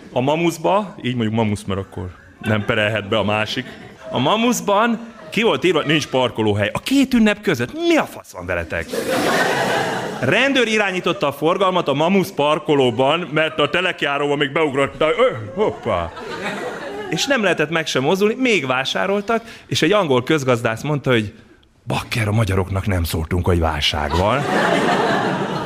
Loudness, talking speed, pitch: -18 LUFS, 155 wpm, 145 Hz